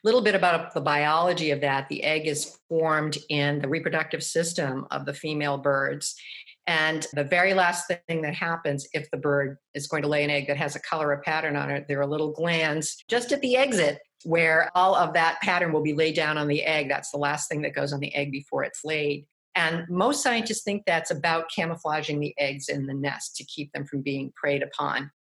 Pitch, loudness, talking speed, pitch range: 155 Hz, -26 LUFS, 225 wpm, 145-165 Hz